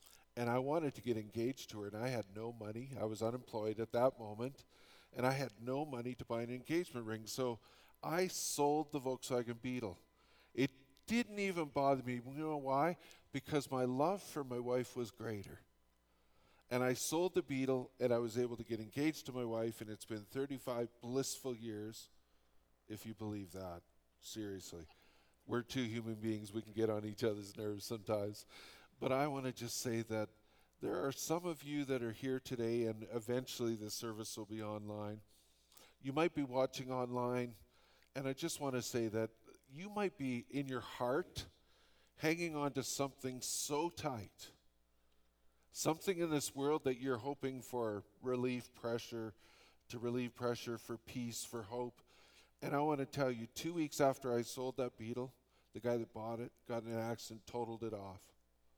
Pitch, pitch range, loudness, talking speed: 120 Hz, 110-135 Hz, -41 LUFS, 180 wpm